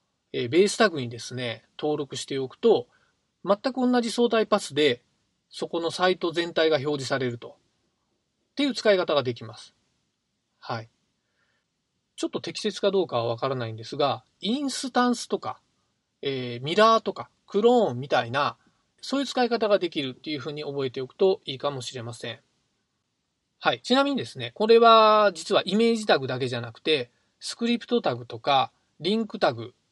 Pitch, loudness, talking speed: 165 Hz, -25 LUFS, 340 characters per minute